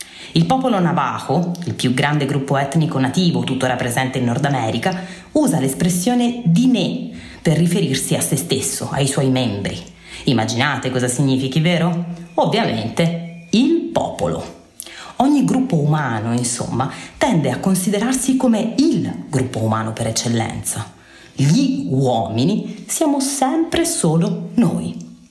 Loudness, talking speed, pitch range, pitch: -18 LUFS, 125 wpm, 130-210 Hz, 165 Hz